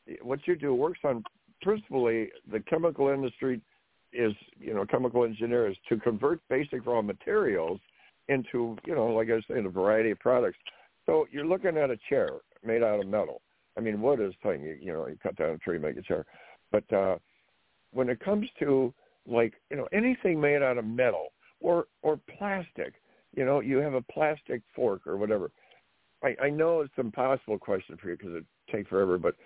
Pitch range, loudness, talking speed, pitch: 120-195 Hz, -30 LUFS, 195 wpm, 135 Hz